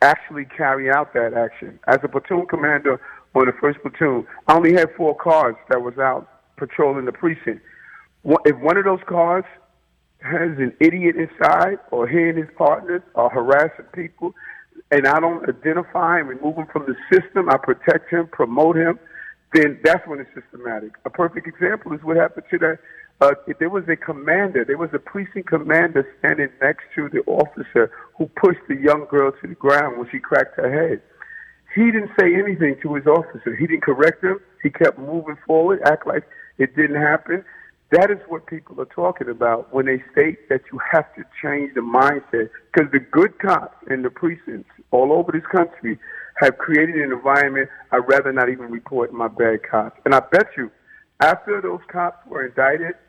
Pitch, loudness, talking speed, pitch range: 155 Hz, -19 LUFS, 185 wpm, 135-170 Hz